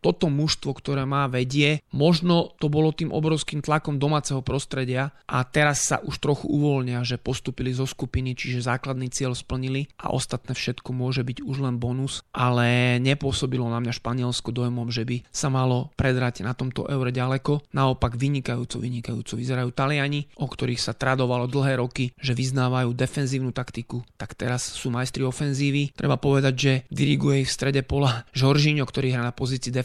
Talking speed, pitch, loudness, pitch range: 165 wpm, 130 Hz, -25 LUFS, 125-140 Hz